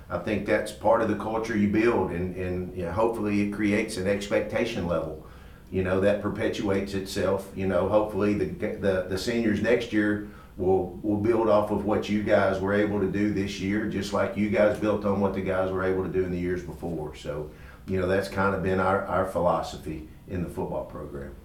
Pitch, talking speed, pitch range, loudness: 100 Hz, 220 wpm, 95-105 Hz, -26 LUFS